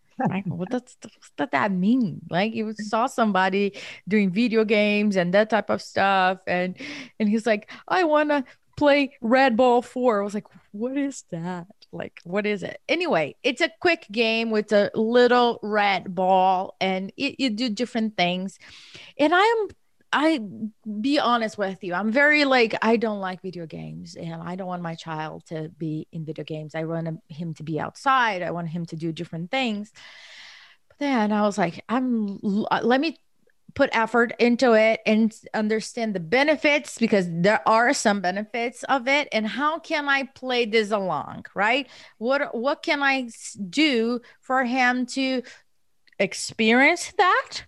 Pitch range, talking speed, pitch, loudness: 190-255 Hz, 170 wpm, 220 Hz, -23 LUFS